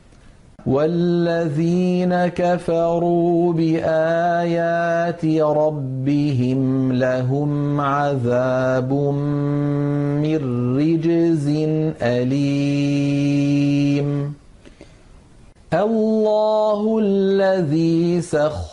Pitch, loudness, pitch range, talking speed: 155 Hz, -19 LUFS, 140-170 Hz, 40 wpm